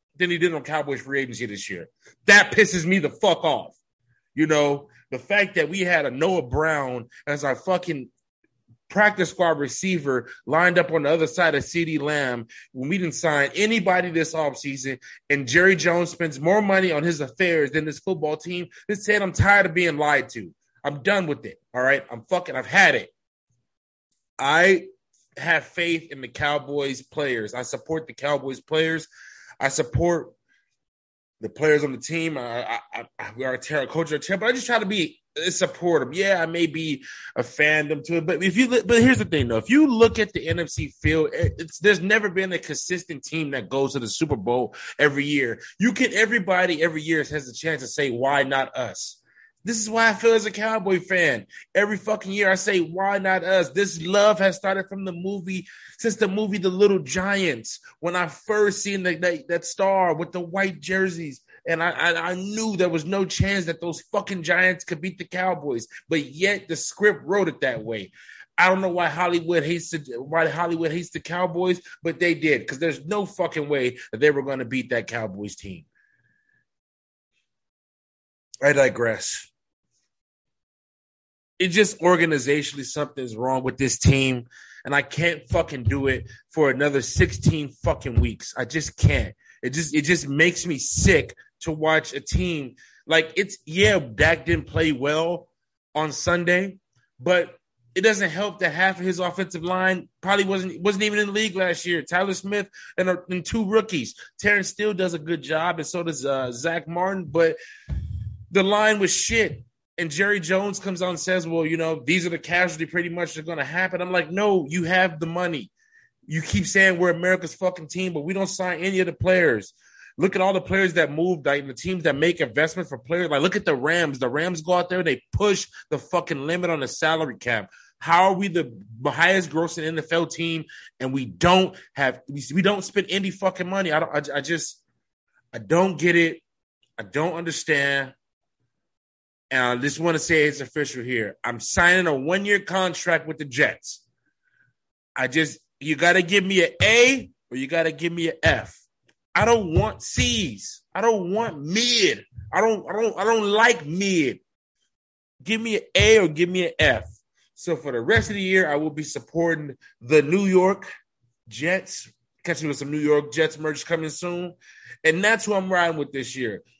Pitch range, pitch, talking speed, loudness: 145-190 Hz, 170 Hz, 195 wpm, -22 LUFS